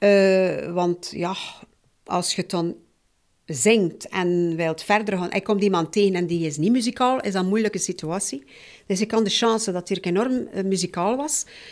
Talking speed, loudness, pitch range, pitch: 180 wpm, -23 LUFS, 175-210 Hz, 190 Hz